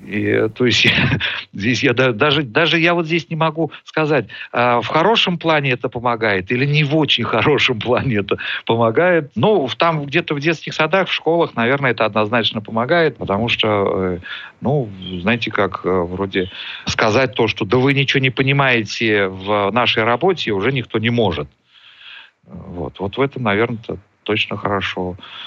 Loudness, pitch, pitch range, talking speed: -17 LUFS, 120 Hz, 105-155 Hz, 155 wpm